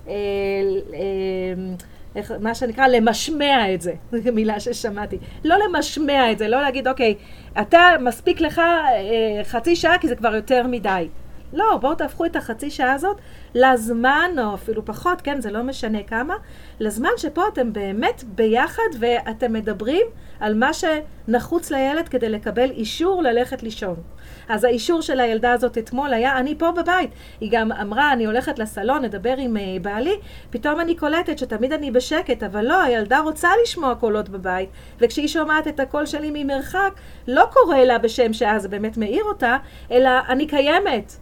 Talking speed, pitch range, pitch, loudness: 160 wpm, 220-305 Hz, 250 Hz, -20 LUFS